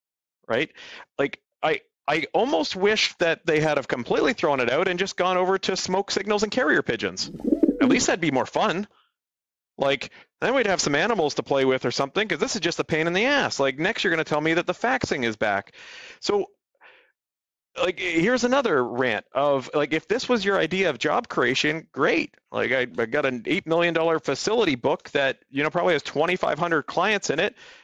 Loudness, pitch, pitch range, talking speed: -23 LUFS, 185 Hz, 155-255 Hz, 210 wpm